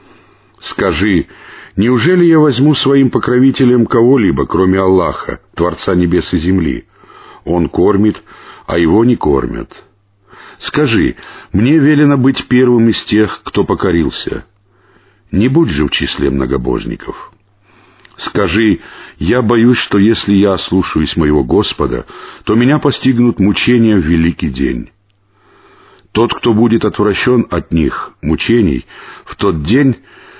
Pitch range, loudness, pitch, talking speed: 95-125 Hz, -12 LUFS, 110 Hz, 120 wpm